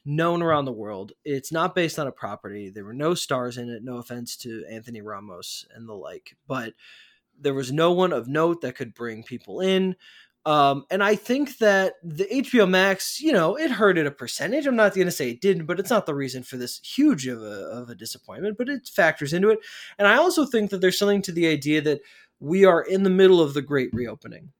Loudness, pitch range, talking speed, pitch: -22 LUFS, 130-195 Hz, 235 wpm, 165 Hz